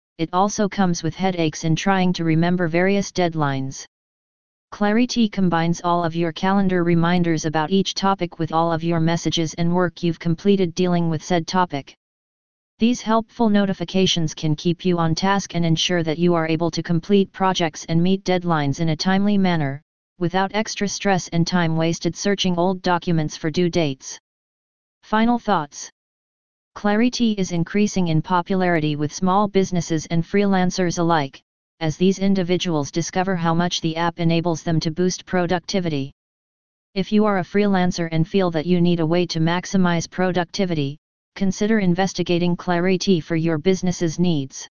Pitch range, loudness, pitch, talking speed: 165-190 Hz, -21 LUFS, 175 Hz, 160 wpm